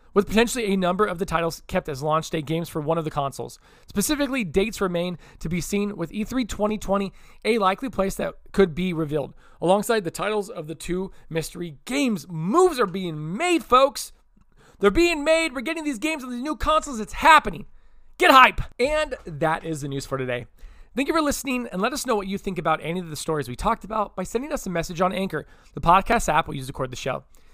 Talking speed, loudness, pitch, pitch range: 225 wpm, -23 LUFS, 195 Hz, 165-235 Hz